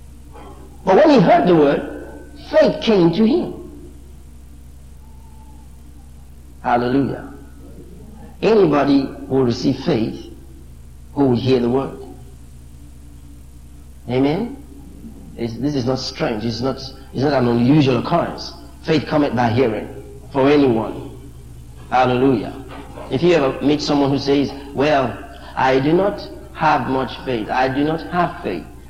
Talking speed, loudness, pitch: 125 wpm, -17 LUFS, 115 Hz